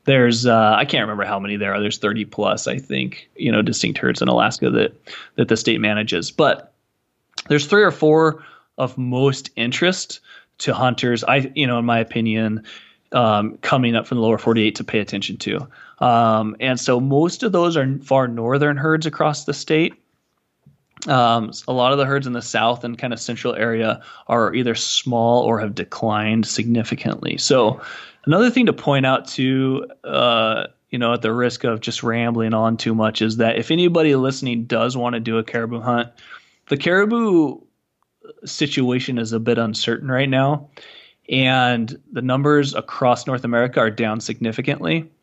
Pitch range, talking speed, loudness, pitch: 115-140 Hz, 180 wpm, -19 LUFS, 120 Hz